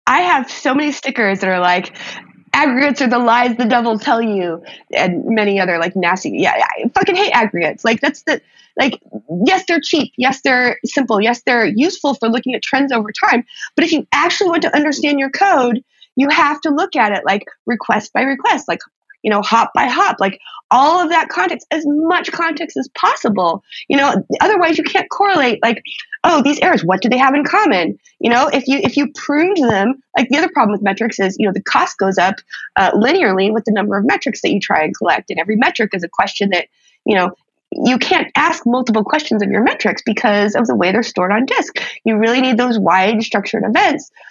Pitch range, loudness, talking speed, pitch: 220-310 Hz, -15 LUFS, 220 wpm, 250 Hz